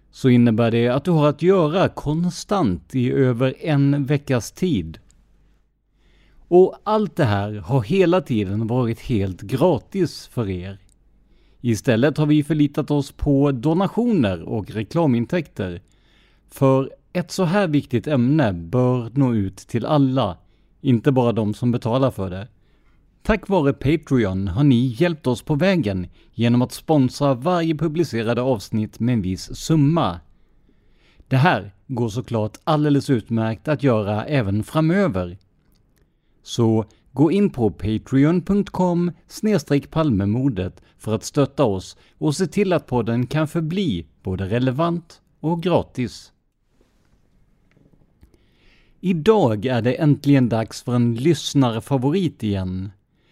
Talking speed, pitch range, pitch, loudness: 125 wpm, 110-155 Hz, 130 Hz, -20 LUFS